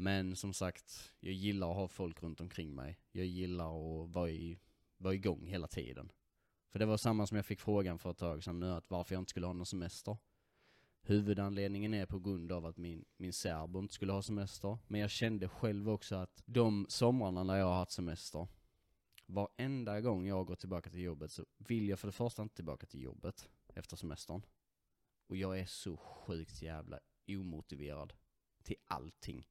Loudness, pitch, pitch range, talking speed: -41 LUFS, 95 Hz, 85-100 Hz, 190 wpm